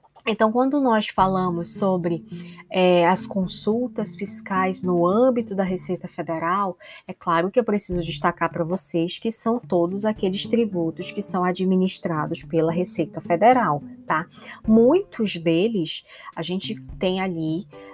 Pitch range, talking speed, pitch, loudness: 175-215 Hz, 135 wpm, 185 Hz, -22 LUFS